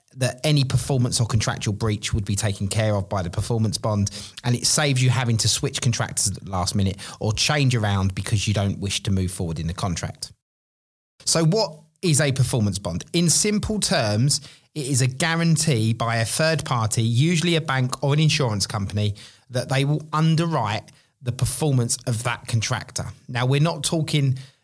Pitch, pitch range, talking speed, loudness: 125 Hz, 105-145 Hz, 190 wpm, -22 LUFS